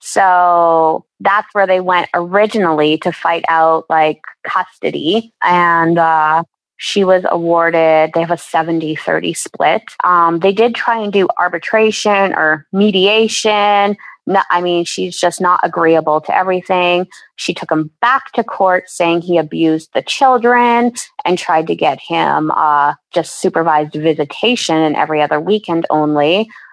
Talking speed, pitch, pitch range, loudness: 145 wpm, 175 Hz, 160-200 Hz, -13 LUFS